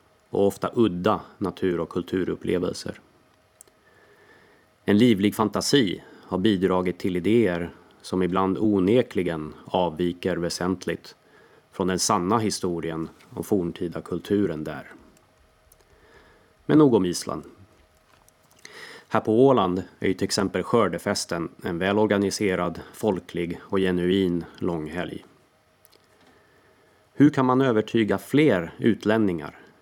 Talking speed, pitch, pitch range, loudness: 100 wpm, 95 Hz, 85-105 Hz, -24 LUFS